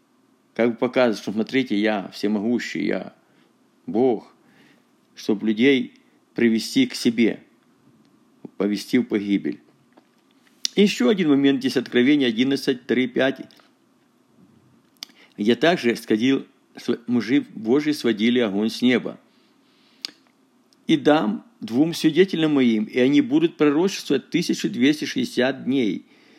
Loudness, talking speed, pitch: -21 LUFS, 100 wpm, 145 Hz